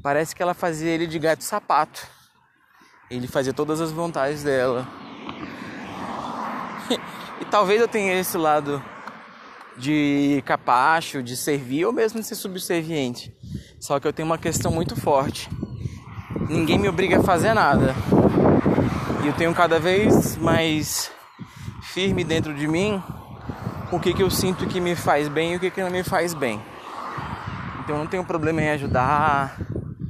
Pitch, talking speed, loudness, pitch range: 160 Hz, 155 wpm, -22 LUFS, 140-180 Hz